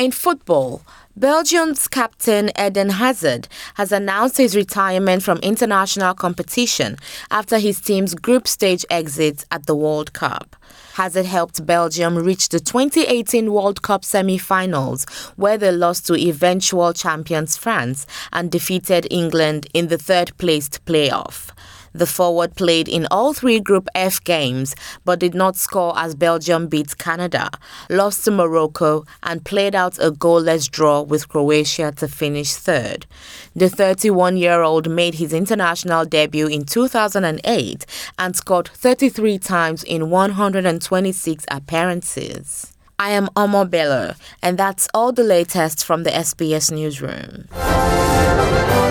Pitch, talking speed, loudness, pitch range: 175 Hz, 130 wpm, -18 LUFS, 160-200 Hz